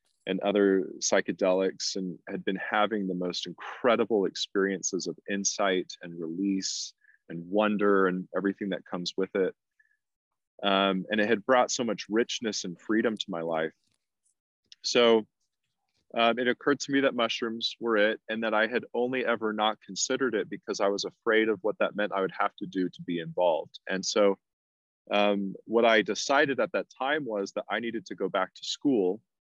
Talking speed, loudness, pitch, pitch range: 180 wpm, -28 LUFS, 100 Hz, 95-110 Hz